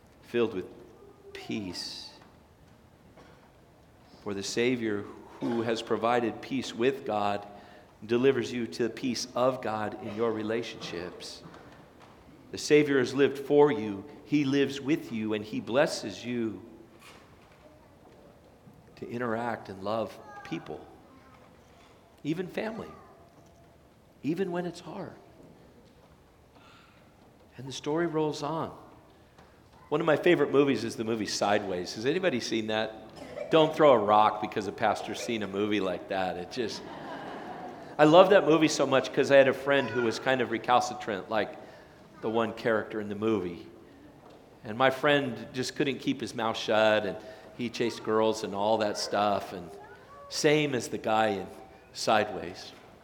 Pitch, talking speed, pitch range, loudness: 115 Hz, 145 wpm, 110-140 Hz, -28 LUFS